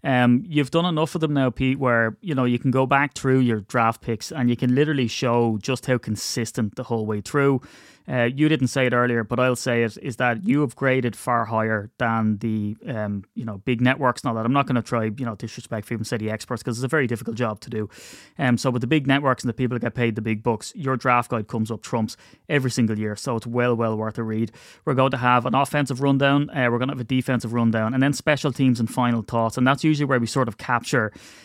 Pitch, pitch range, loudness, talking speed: 125 Hz, 115-130 Hz, -23 LUFS, 265 wpm